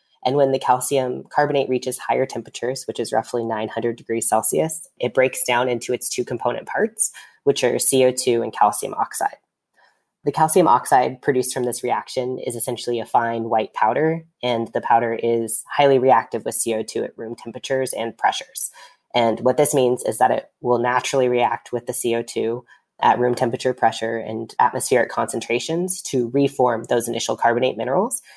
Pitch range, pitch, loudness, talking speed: 115-130 Hz, 125 Hz, -20 LUFS, 170 wpm